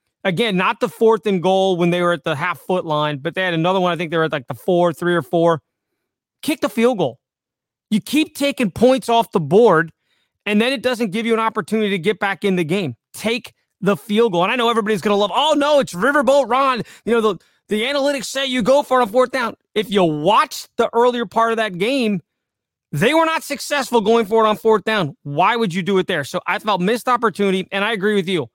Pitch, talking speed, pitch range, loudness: 215 Hz, 250 wpm, 180-240 Hz, -18 LUFS